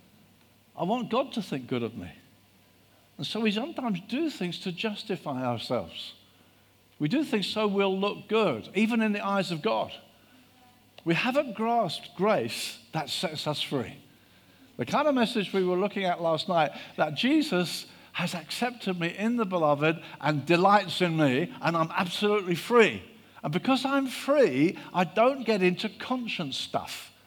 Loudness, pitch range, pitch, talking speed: -28 LUFS, 145-220 Hz, 180 Hz, 165 wpm